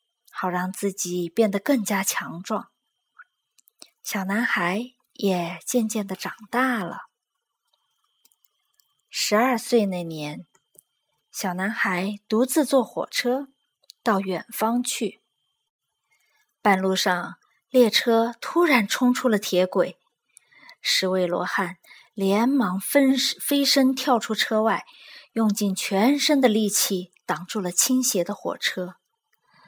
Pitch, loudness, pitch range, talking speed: 215 Hz, -23 LUFS, 190-255 Hz, 155 characters per minute